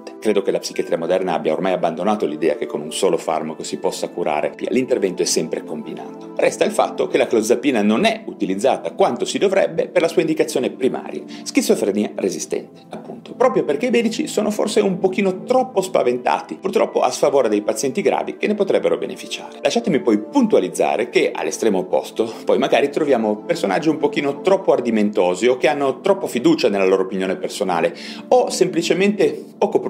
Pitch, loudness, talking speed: 195 Hz, -19 LUFS, 175 wpm